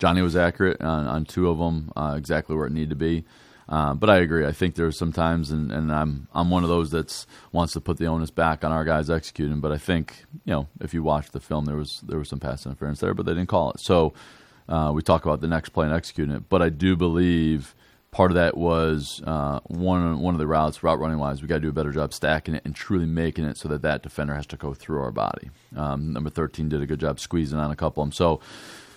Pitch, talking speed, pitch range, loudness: 80 Hz, 270 wpm, 75-85 Hz, -25 LUFS